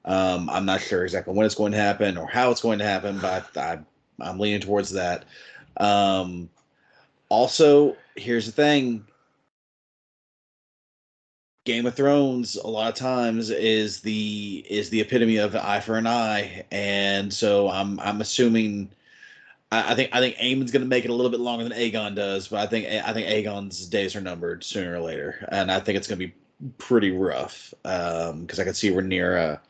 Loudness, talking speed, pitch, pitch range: -24 LUFS, 195 wpm, 105 Hz, 100-120 Hz